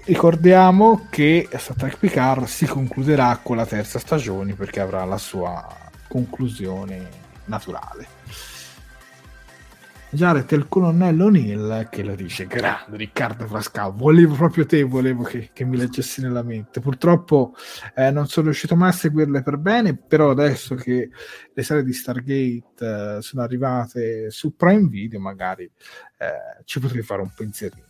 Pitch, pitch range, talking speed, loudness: 130 Hz, 110-160 Hz, 145 wpm, -20 LUFS